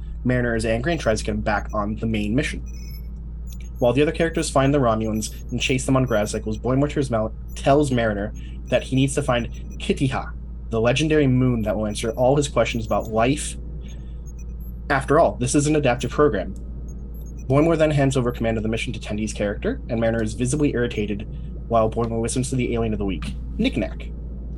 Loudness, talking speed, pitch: -22 LUFS, 195 wpm, 115 Hz